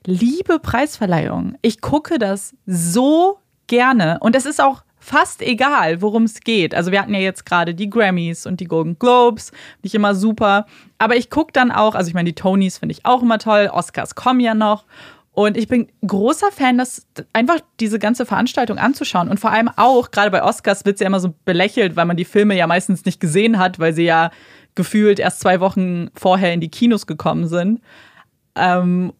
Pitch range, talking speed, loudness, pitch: 185-240 Hz, 200 wpm, -16 LUFS, 210 Hz